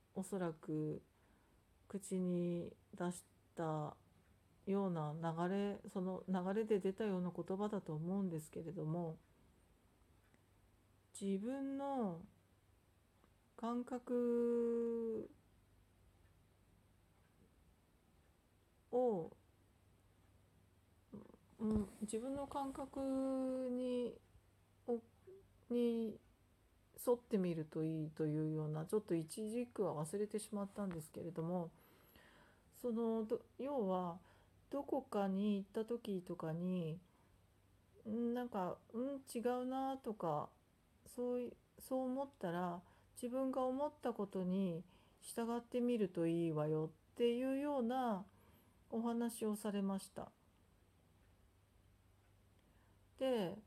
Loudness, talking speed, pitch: -42 LUFS, 160 characters per minute, 180 Hz